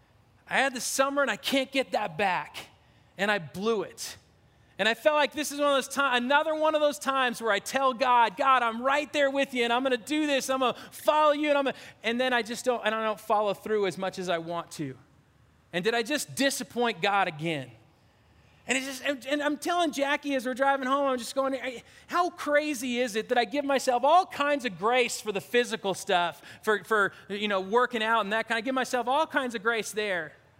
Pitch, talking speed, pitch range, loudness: 245 Hz, 240 wpm, 215-275 Hz, -27 LUFS